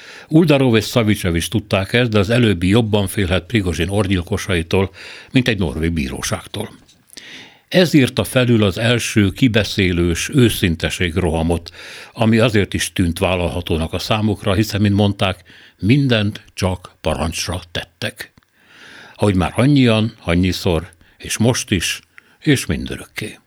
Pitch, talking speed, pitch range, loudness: 100 Hz, 125 wpm, 90-115 Hz, -17 LUFS